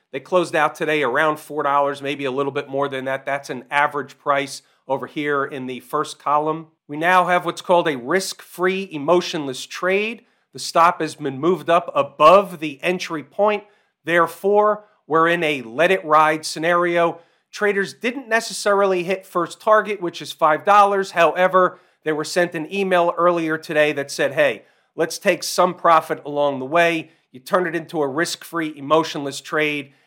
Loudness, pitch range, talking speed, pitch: -20 LUFS, 145-180 Hz, 175 wpm, 165 Hz